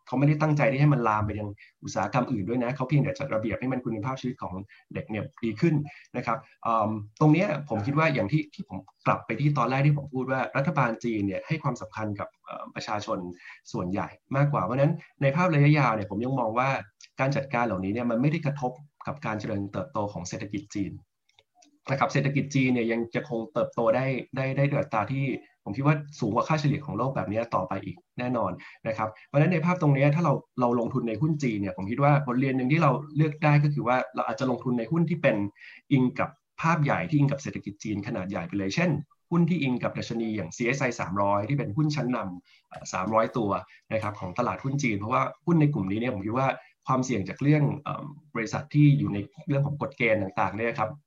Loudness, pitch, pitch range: -27 LUFS, 130 Hz, 115-145 Hz